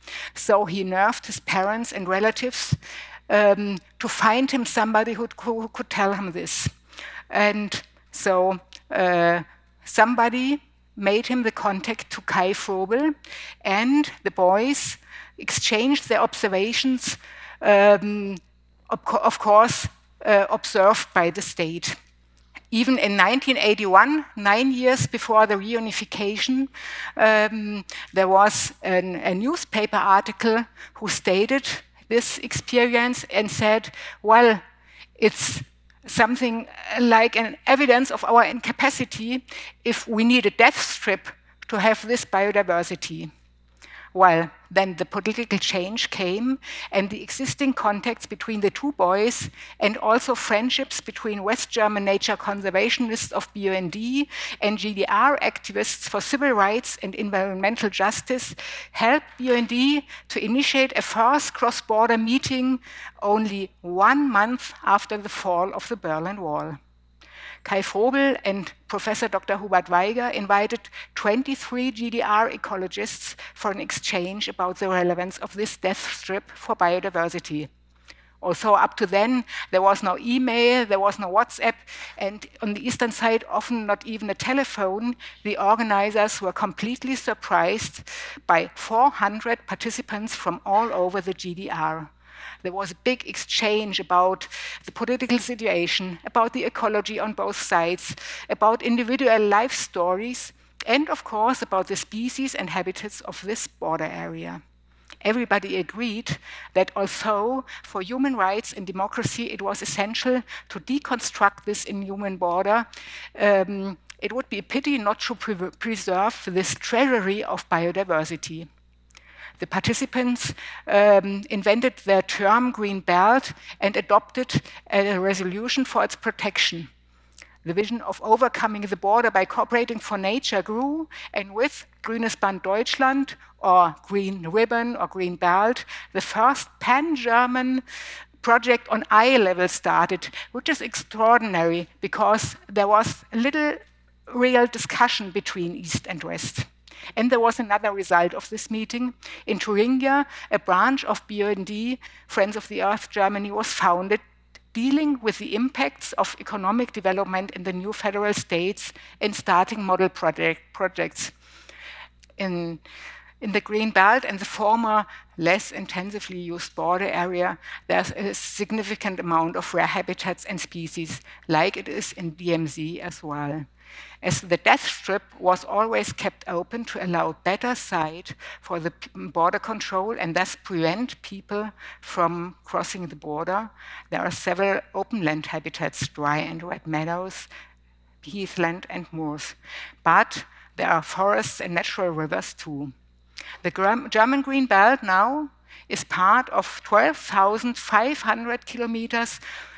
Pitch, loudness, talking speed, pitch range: 205 Hz, -23 LUFS, 130 wpm, 185-235 Hz